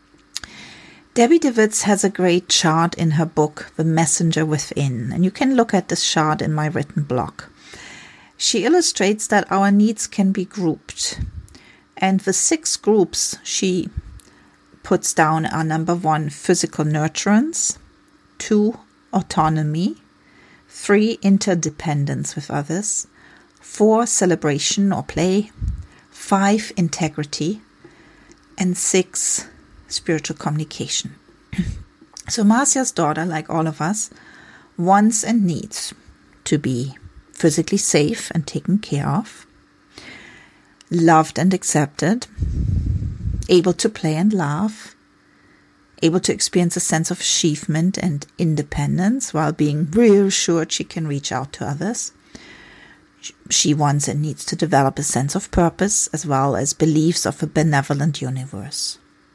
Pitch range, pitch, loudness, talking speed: 155-200 Hz, 170 Hz, -19 LUFS, 125 wpm